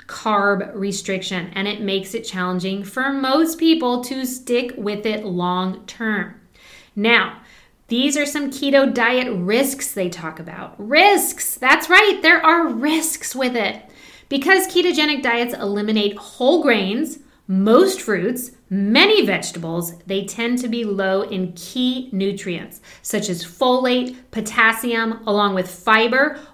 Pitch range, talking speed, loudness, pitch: 200-275 Hz, 135 wpm, -18 LUFS, 230 Hz